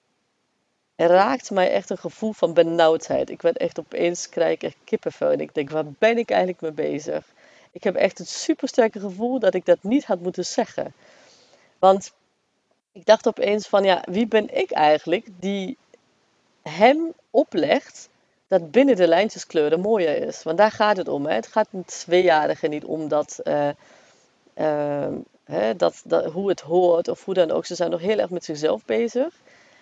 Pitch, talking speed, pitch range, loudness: 190 Hz, 180 wpm, 170-230 Hz, -22 LUFS